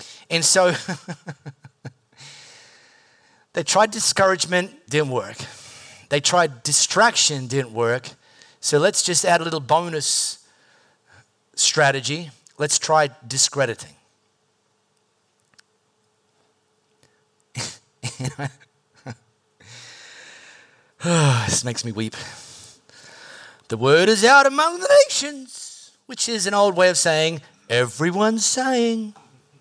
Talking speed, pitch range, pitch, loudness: 85 wpm, 130-195 Hz, 155 Hz, -19 LUFS